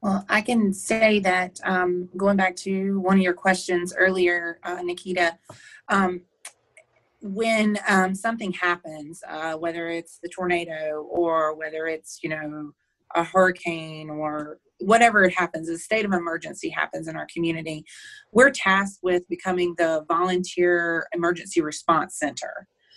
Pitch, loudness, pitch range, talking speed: 180 Hz, -23 LUFS, 165-190 Hz, 140 wpm